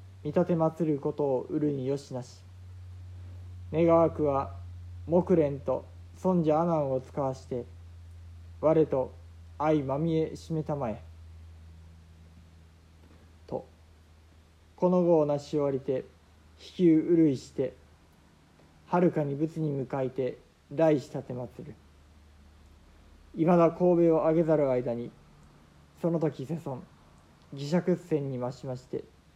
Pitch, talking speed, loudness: 125 Hz, 210 characters per minute, -28 LUFS